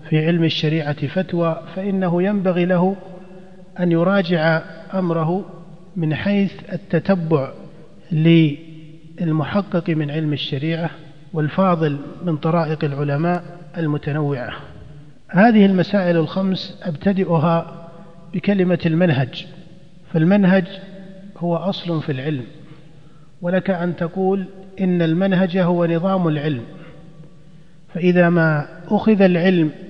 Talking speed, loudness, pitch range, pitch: 90 wpm, -19 LUFS, 160-185 Hz, 170 Hz